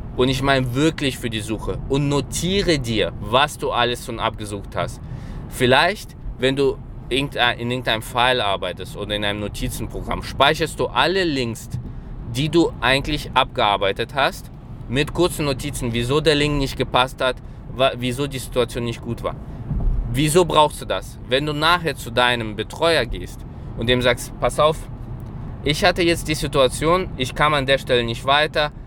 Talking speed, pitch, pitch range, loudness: 165 wpm, 130 Hz, 120-145 Hz, -20 LUFS